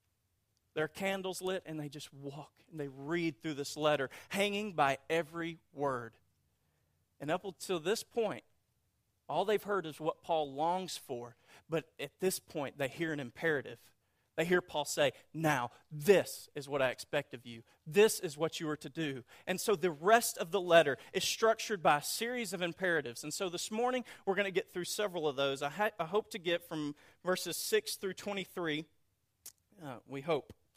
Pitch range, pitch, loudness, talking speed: 140-190 Hz, 160 Hz, -35 LUFS, 190 wpm